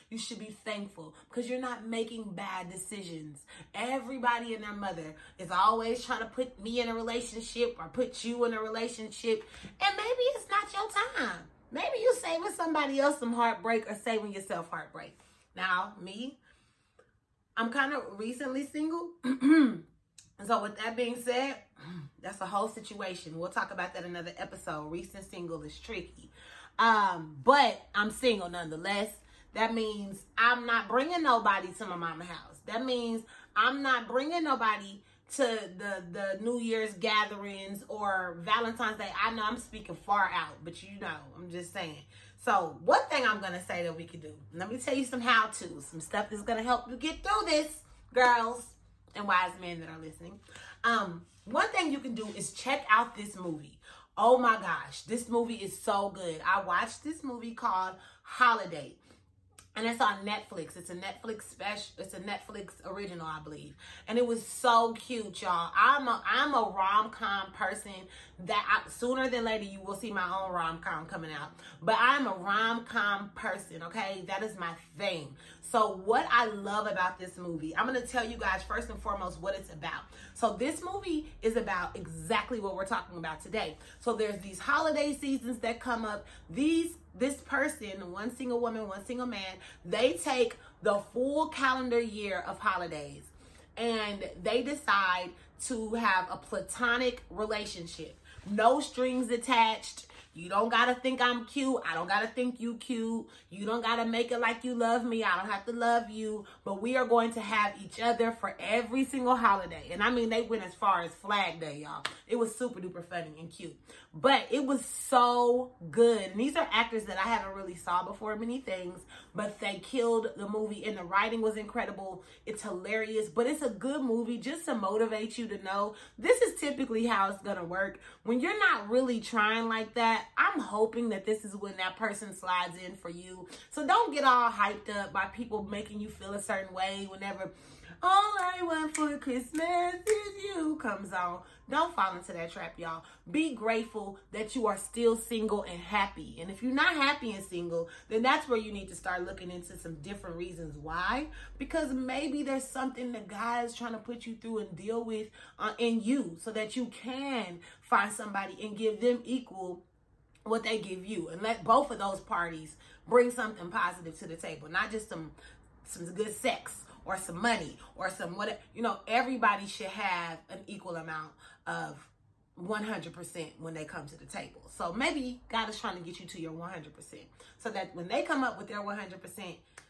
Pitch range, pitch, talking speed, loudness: 185-240 Hz, 215 Hz, 190 wpm, -32 LUFS